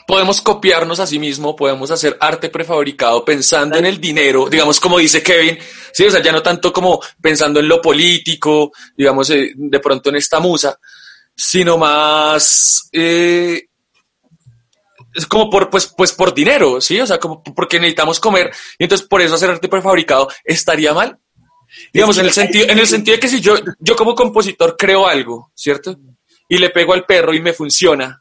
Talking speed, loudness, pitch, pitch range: 180 wpm, -12 LUFS, 165 Hz, 150-185 Hz